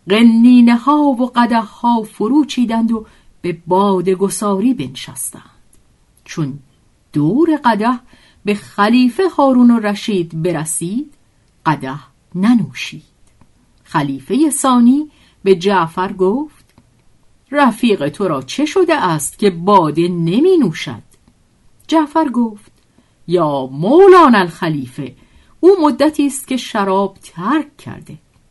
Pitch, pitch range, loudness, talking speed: 215 Hz, 175-265 Hz, -14 LUFS, 105 wpm